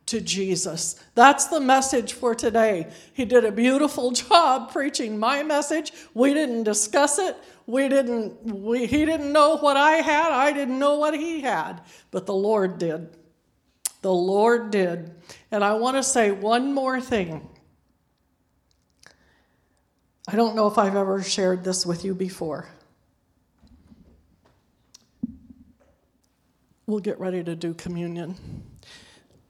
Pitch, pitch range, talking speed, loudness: 230 Hz, 190-275 Hz, 135 wpm, -22 LUFS